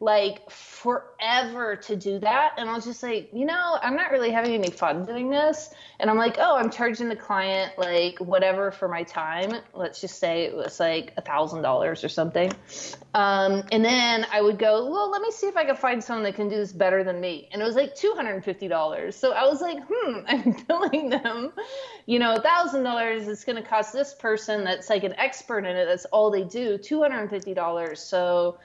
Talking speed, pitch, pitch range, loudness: 230 wpm, 220 Hz, 195-265 Hz, -25 LUFS